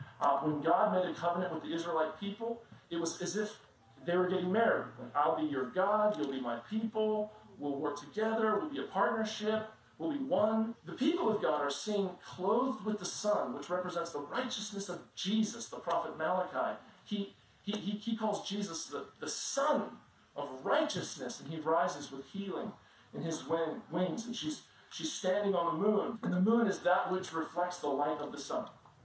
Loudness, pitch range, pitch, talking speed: -35 LUFS, 160-215 Hz, 185 Hz, 195 wpm